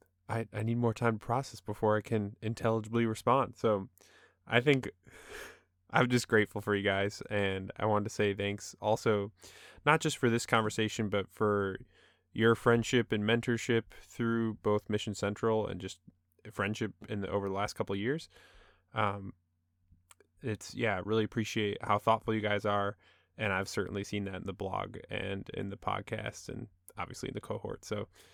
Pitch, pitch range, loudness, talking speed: 105 Hz, 100-115 Hz, -33 LUFS, 175 wpm